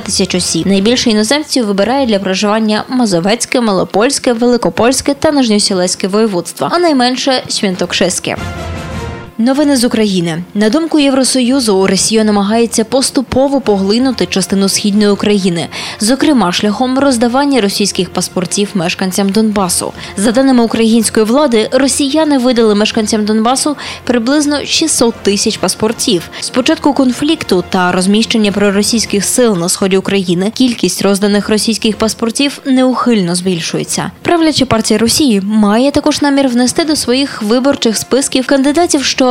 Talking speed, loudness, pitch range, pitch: 115 wpm, -11 LUFS, 200-265 Hz, 225 Hz